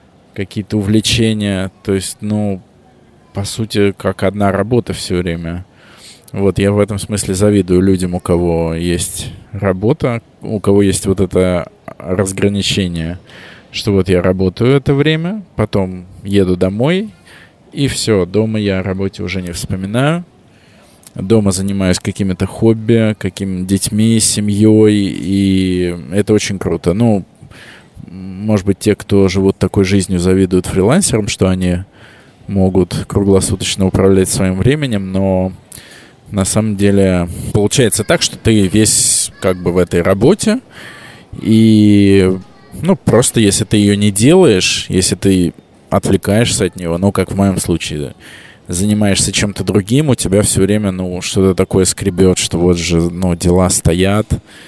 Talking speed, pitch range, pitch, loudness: 135 wpm, 95-110 Hz, 100 Hz, -13 LUFS